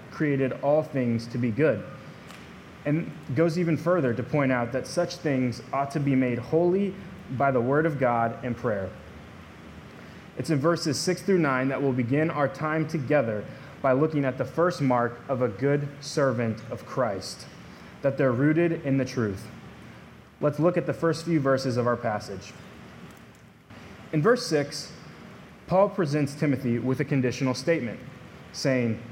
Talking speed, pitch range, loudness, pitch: 165 wpm, 125-160 Hz, -26 LUFS, 140 Hz